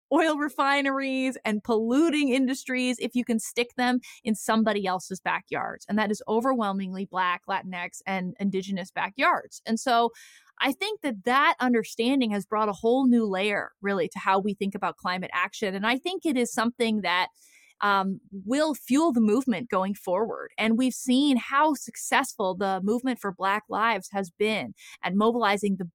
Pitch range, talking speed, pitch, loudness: 195-255 Hz, 170 wpm, 220 Hz, -26 LUFS